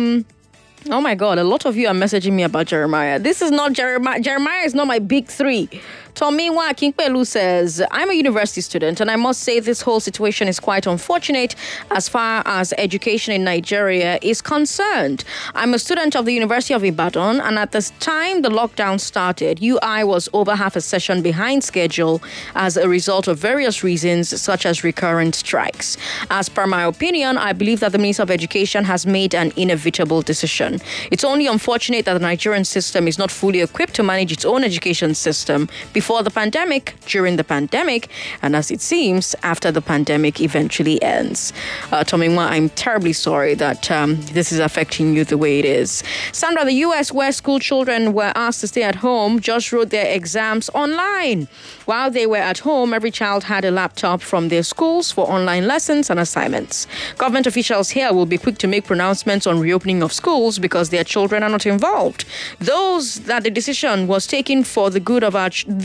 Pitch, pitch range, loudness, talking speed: 205 Hz, 175-245 Hz, -17 LUFS, 190 wpm